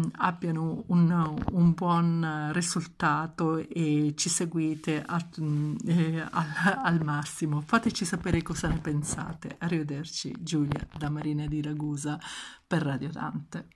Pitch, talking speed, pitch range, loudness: 160 Hz, 115 wpm, 150-170 Hz, -29 LUFS